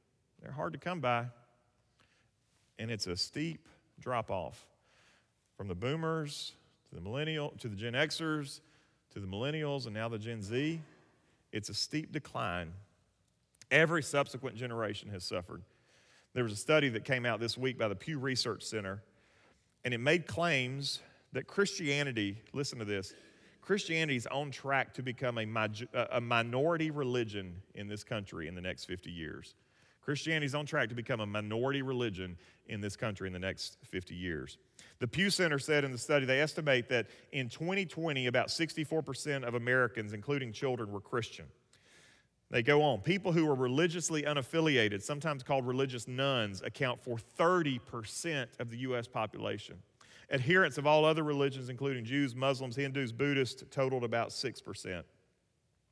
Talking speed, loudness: 160 wpm, -34 LUFS